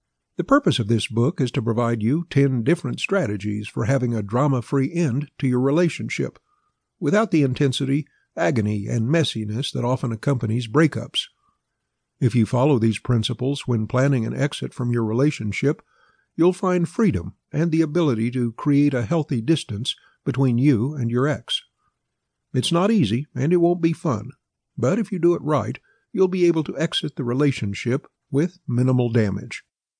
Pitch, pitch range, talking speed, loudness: 135 Hz, 120-165 Hz, 165 wpm, -22 LUFS